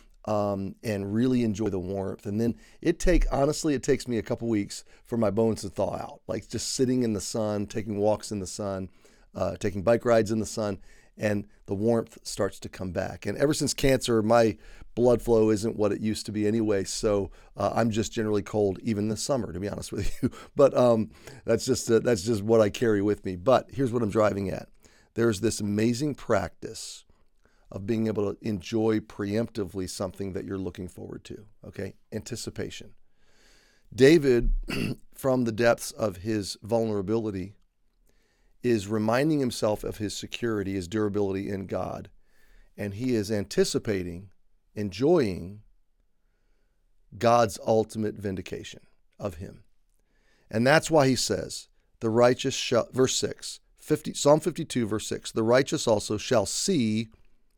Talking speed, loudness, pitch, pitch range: 165 wpm, -27 LUFS, 110 Hz, 100-120 Hz